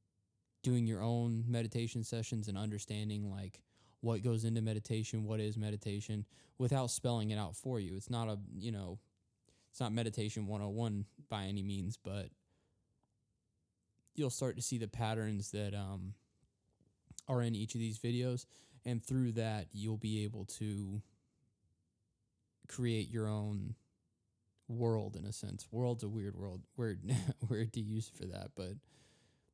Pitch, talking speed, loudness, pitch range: 110 Hz, 150 wpm, -40 LUFS, 100-115 Hz